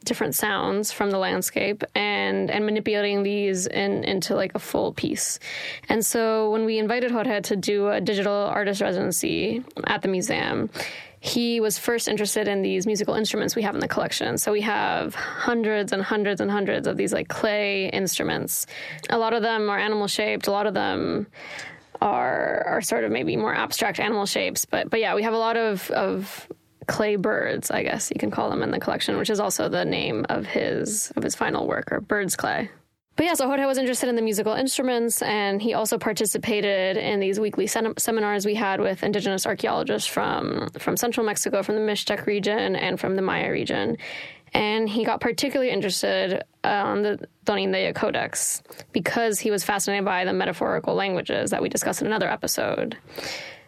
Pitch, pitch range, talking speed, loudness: 210 Hz, 200-225 Hz, 190 wpm, -24 LUFS